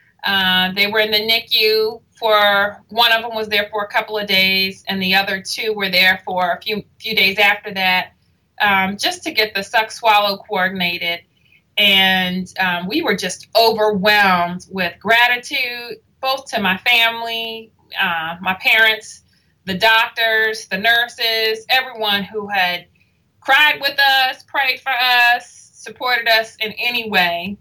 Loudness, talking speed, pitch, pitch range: -16 LUFS, 155 wpm, 215 Hz, 190-230 Hz